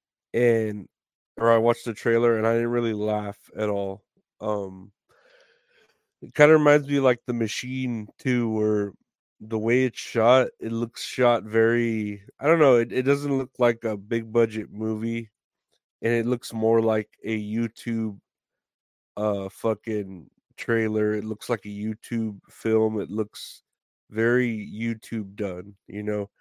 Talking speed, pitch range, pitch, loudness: 150 wpm, 105-120 Hz, 115 Hz, -25 LUFS